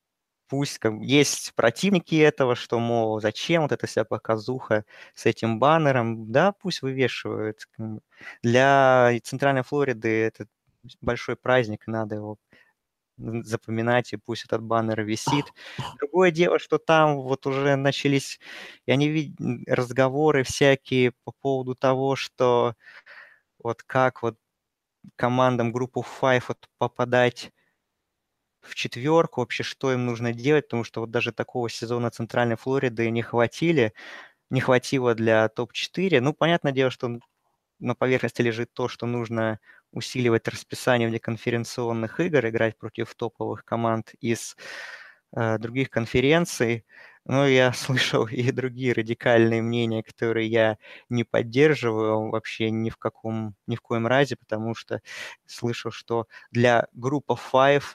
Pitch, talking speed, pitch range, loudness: 120 Hz, 130 wpm, 115-135 Hz, -24 LUFS